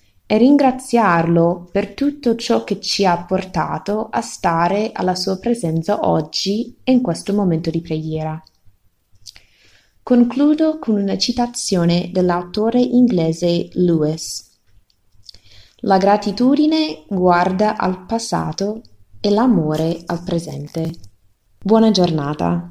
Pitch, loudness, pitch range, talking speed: 175 Hz, -17 LUFS, 155-220 Hz, 105 wpm